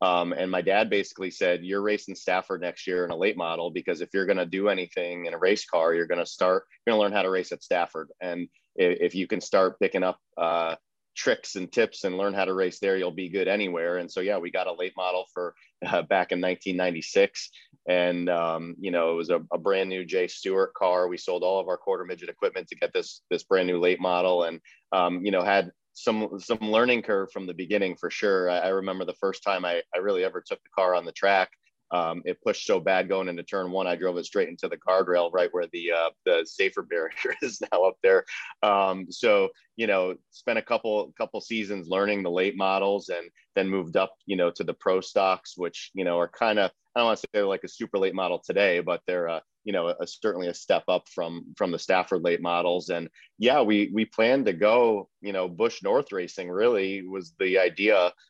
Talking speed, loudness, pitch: 240 wpm, -26 LUFS, 95 Hz